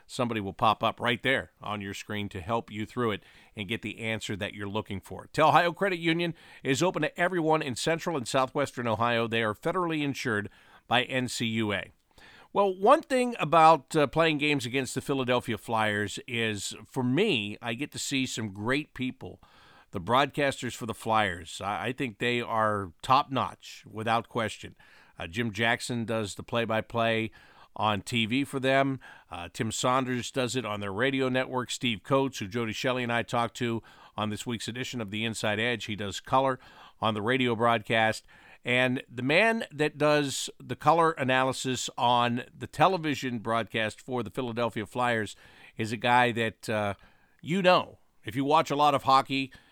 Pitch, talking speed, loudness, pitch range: 120 Hz, 180 wpm, -28 LUFS, 110-135 Hz